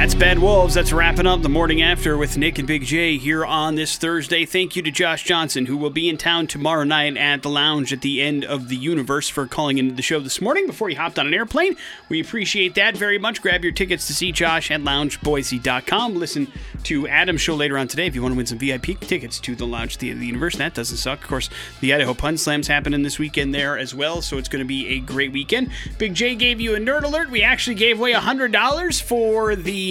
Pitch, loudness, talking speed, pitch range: 160 Hz, -19 LUFS, 255 wpm, 140-190 Hz